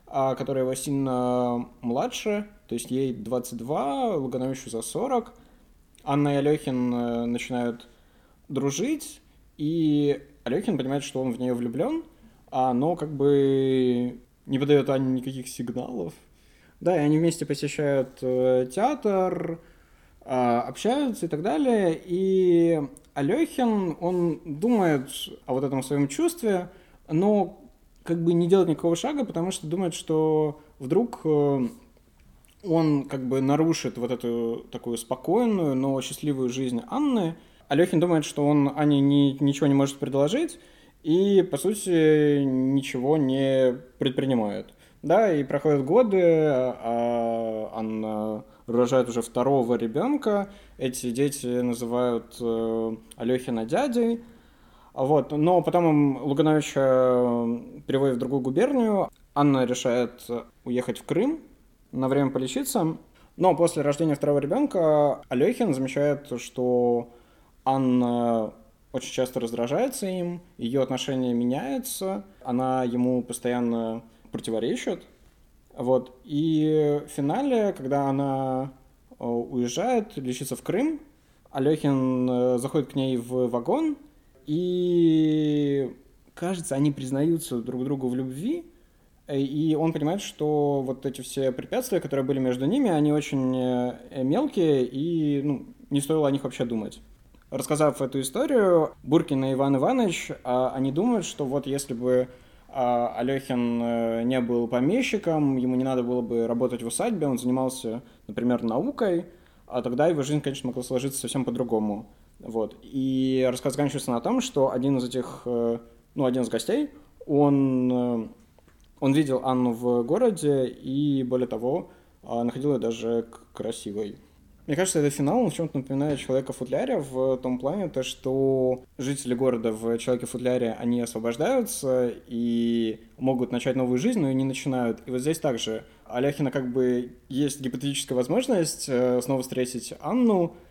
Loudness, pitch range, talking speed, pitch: -25 LUFS, 125-160 Hz, 125 wpm, 135 Hz